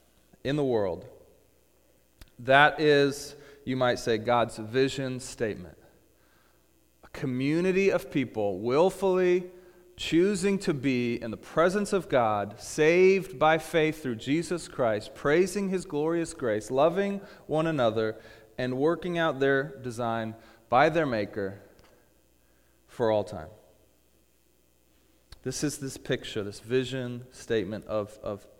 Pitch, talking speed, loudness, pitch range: 130 Hz, 120 wpm, -27 LUFS, 110-160 Hz